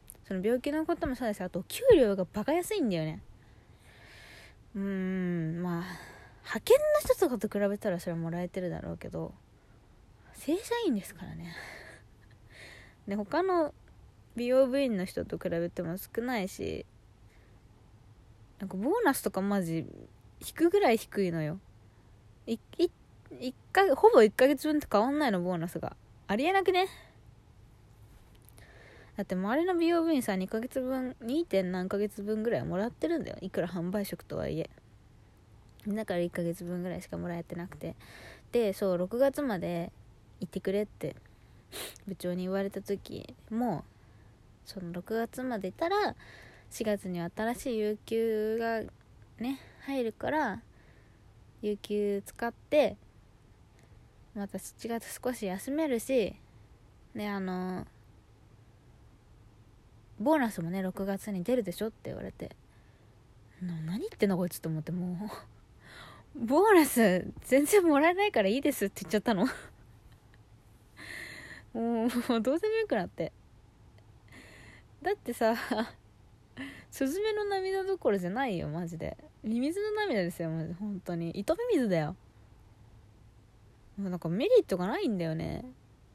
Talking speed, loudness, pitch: 260 characters per minute, -31 LUFS, 185 Hz